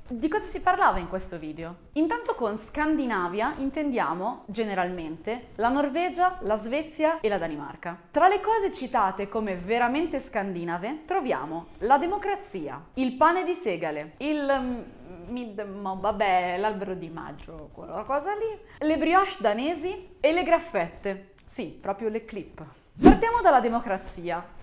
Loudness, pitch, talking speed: -26 LUFS, 240 Hz, 135 wpm